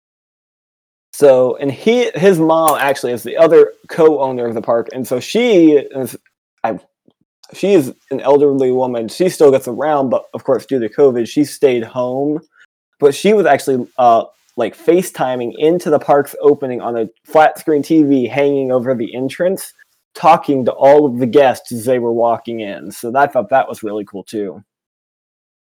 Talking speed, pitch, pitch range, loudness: 175 wpm, 135 Hz, 120-160 Hz, -14 LUFS